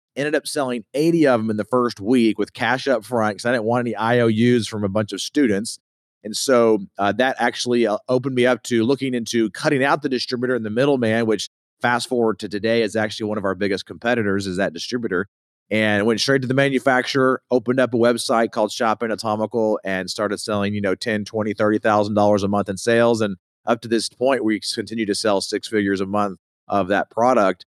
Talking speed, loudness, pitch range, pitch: 220 wpm, -20 LUFS, 105-125 Hz, 110 Hz